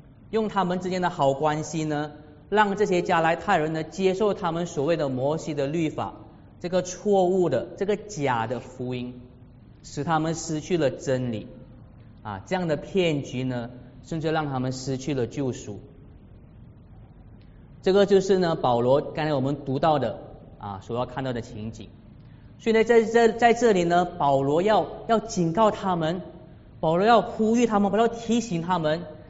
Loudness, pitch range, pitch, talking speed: -24 LUFS, 125-185 Hz, 155 Hz, 240 characters per minute